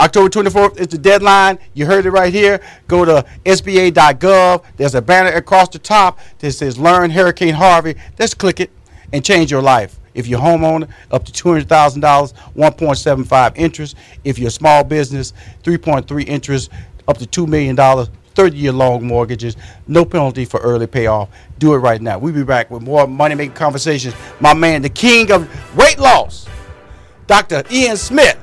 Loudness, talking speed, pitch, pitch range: -12 LUFS, 170 wpm, 150 Hz, 125-180 Hz